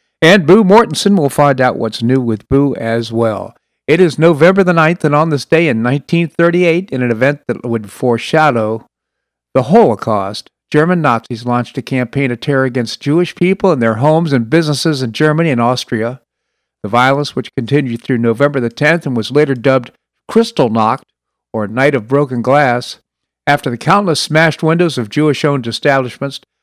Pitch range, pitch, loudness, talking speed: 120-160 Hz, 140 Hz, -13 LUFS, 175 wpm